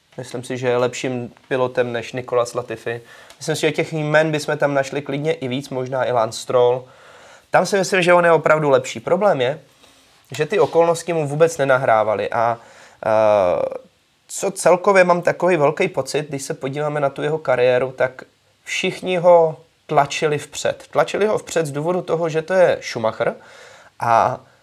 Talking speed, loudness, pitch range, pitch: 170 wpm, -19 LUFS, 125-165 Hz, 145 Hz